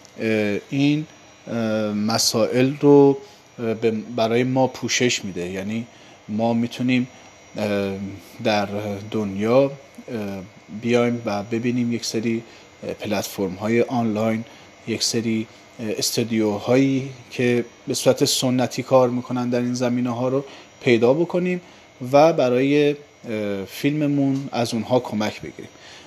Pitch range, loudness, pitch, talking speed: 110-130 Hz, -21 LUFS, 120 Hz, 100 wpm